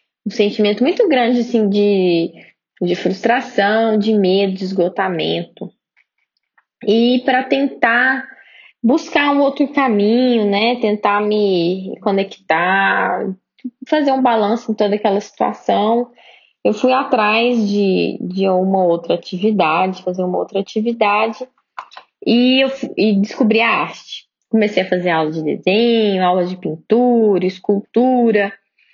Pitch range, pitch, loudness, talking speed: 195-245 Hz, 210 Hz, -16 LUFS, 120 wpm